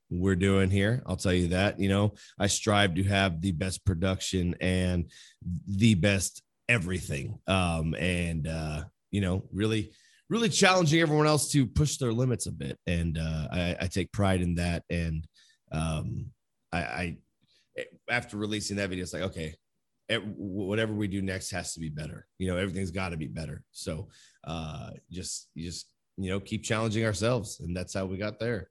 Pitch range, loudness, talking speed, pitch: 90-105 Hz, -29 LUFS, 180 wpm, 95 Hz